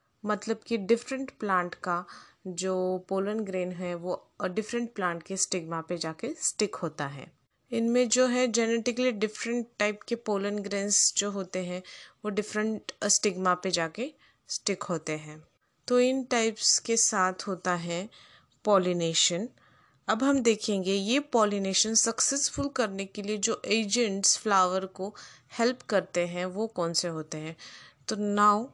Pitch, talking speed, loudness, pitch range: 205 Hz, 145 wpm, -28 LUFS, 185-230 Hz